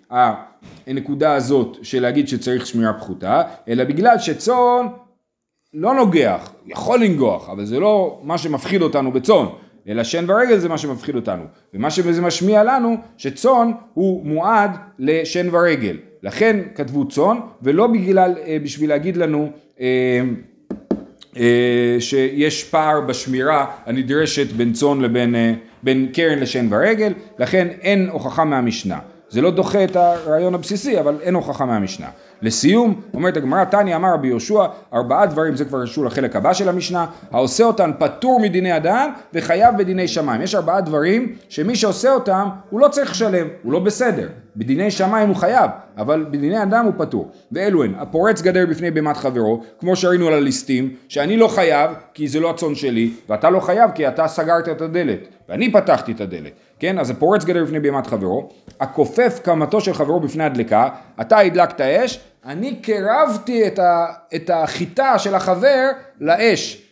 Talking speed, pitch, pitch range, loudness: 155 wpm, 170 Hz, 140-205 Hz, -17 LUFS